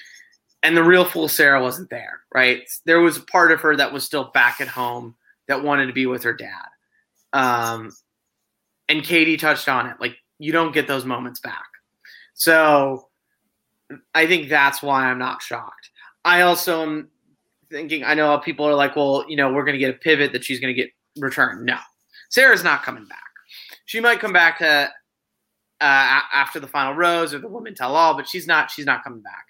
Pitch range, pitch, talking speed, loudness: 135-165 Hz, 150 Hz, 200 wpm, -18 LUFS